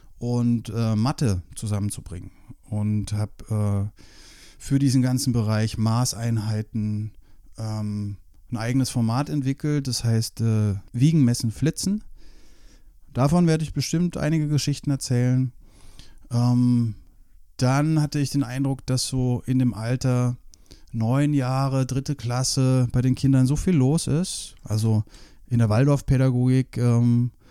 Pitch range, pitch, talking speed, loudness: 110-135 Hz, 125 Hz, 125 wpm, -23 LUFS